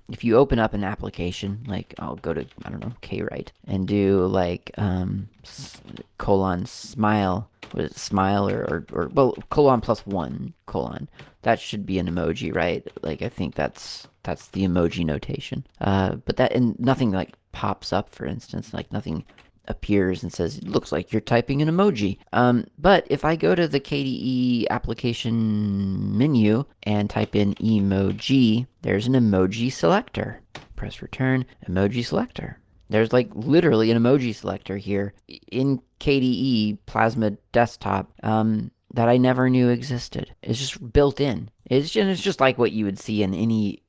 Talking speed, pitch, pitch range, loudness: 165 wpm, 110 Hz, 100-125 Hz, -23 LUFS